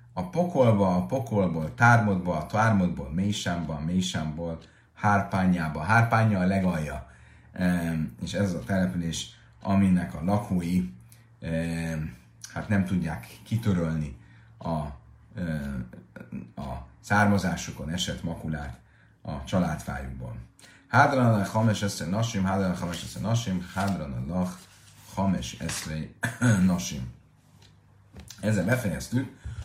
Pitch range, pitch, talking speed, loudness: 80-105 Hz, 90 Hz, 100 wpm, -27 LUFS